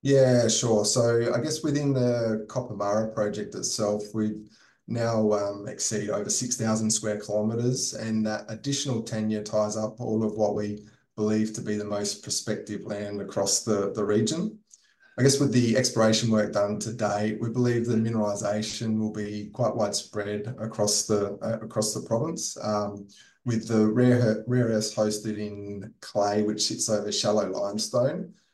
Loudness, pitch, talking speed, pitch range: -26 LUFS, 110 Hz, 160 wpm, 105-115 Hz